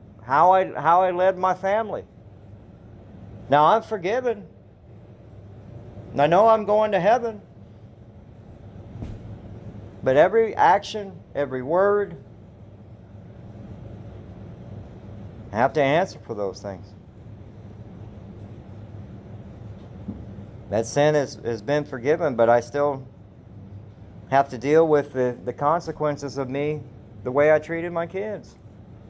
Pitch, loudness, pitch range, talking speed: 115 Hz, -22 LUFS, 100-150 Hz, 105 wpm